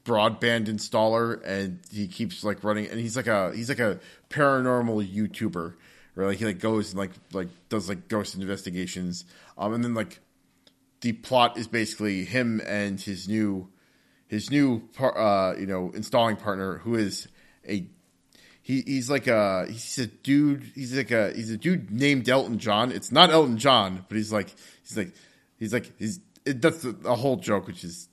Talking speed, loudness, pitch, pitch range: 185 wpm, -26 LUFS, 110 Hz, 100-120 Hz